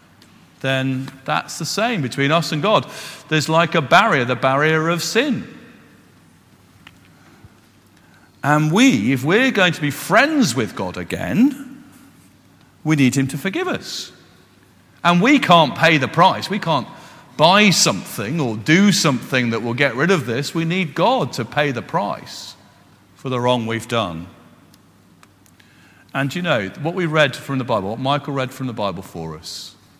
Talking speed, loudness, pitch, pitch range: 160 wpm, -18 LUFS, 140 Hz, 115-170 Hz